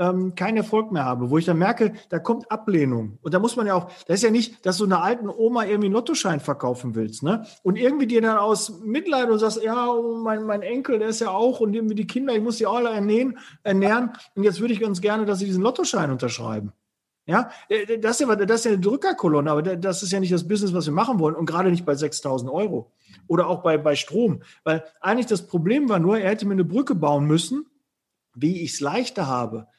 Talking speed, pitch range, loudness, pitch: 235 wpm, 160-230 Hz, -23 LUFS, 200 Hz